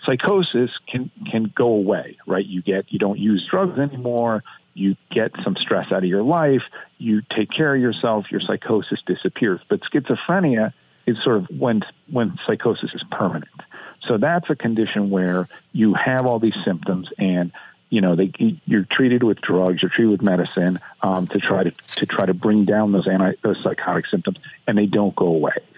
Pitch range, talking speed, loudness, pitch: 95-125 Hz, 185 wpm, -20 LUFS, 105 Hz